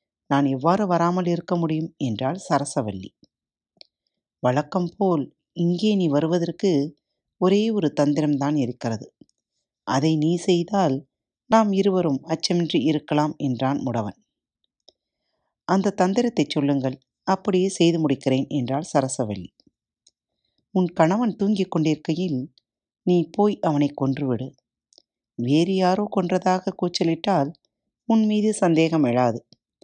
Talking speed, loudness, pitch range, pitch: 100 wpm, -22 LUFS, 140-185 Hz, 160 Hz